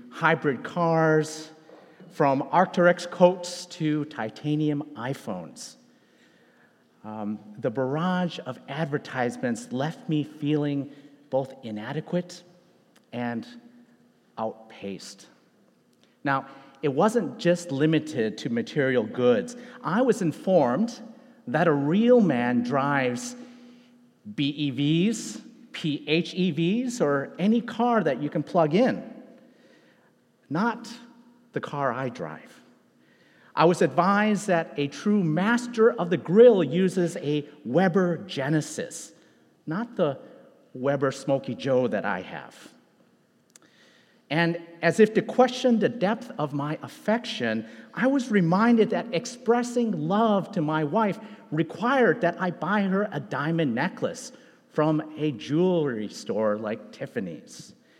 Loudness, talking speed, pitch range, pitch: -25 LUFS, 110 wpm, 145-230 Hz, 170 Hz